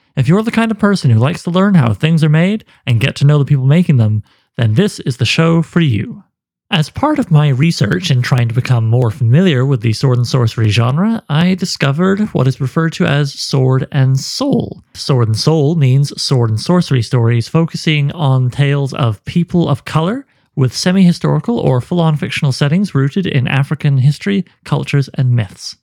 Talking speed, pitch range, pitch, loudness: 200 wpm, 130-170 Hz, 145 Hz, -13 LUFS